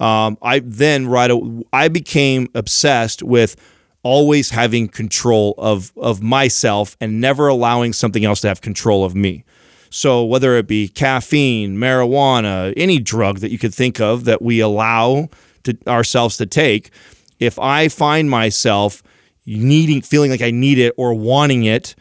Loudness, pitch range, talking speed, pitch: -15 LUFS, 110-130 Hz, 160 wpm, 120 Hz